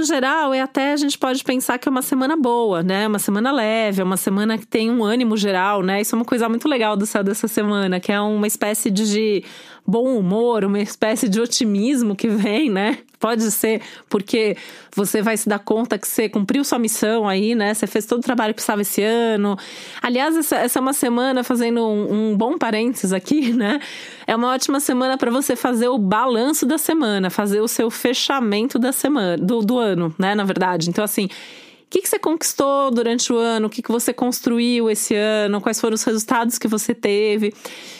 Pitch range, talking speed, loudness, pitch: 210-255 Hz, 210 wpm, -19 LUFS, 230 Hz